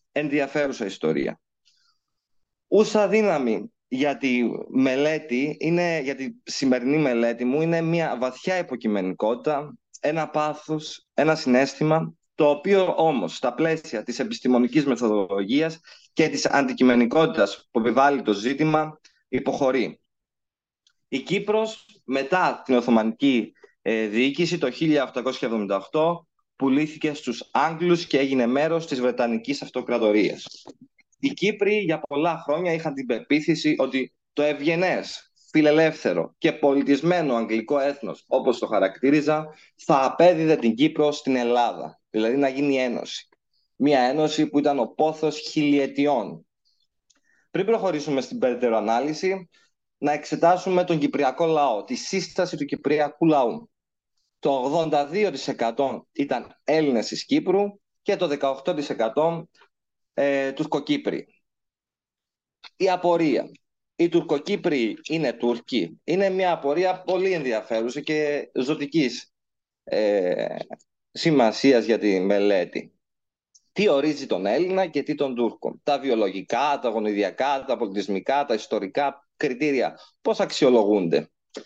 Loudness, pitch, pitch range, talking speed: -23 LUFS, 150 Hz, 130-165 Hz, 110 wpm